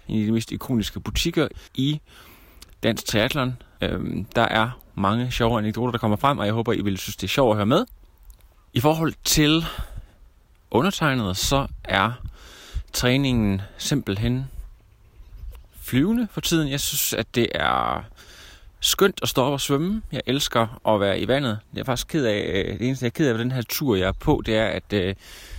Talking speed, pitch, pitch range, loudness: 185 wpm, 115 Hz, 105-140 Hz, -23 LUFS